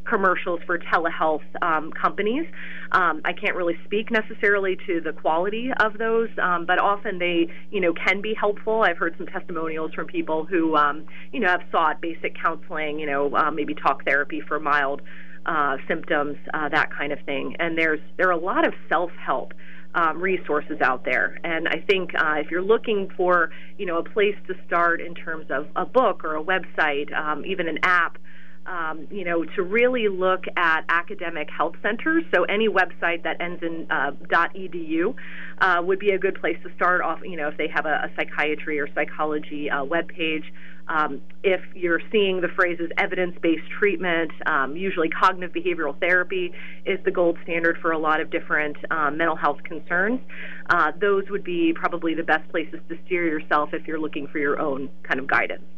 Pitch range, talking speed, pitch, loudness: 155-185 Hz, 190 wpm, 170 Hz, -23 LUFS